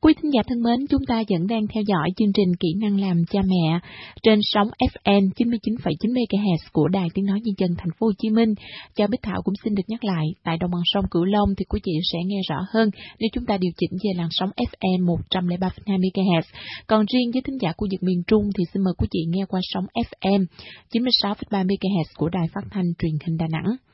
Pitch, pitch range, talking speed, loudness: 195 Hz, 175-220 Hz, 235 wpm, -23 LUFS